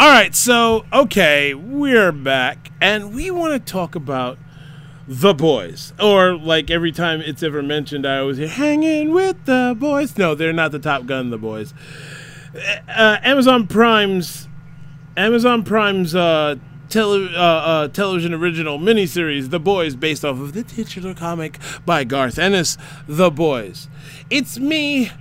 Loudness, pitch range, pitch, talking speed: -17 LUFS, 150-215 Hz, 170 Hz, 150 wpm